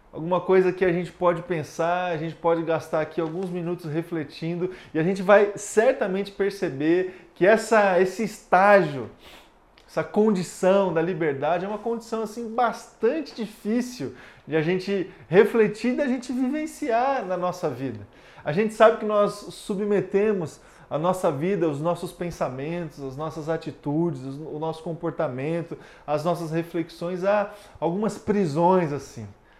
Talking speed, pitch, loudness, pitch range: 145 wpm, 180 Hz, -24 LUFS, 165-205 Hz